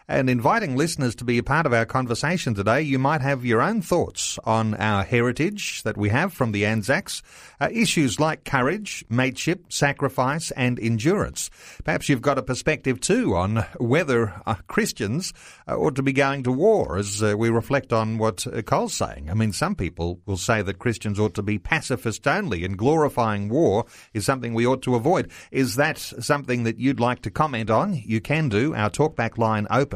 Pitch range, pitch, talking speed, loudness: 110-145 Hz, 125 Hz, 195 wpm, -23 LUFS